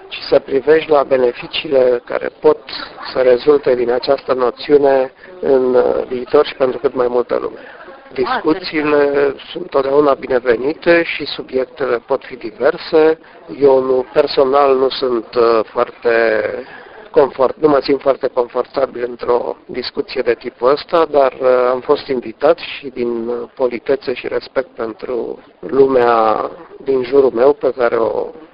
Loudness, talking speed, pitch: -15 LUFS, 130 wpm, 140 Hz